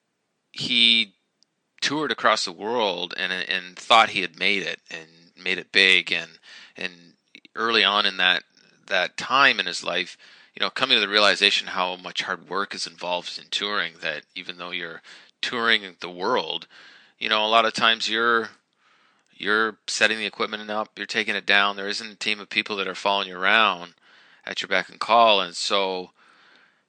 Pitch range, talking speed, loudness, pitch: 90-110 Hz, 185 wpm, -22 LUFS, 100 Hz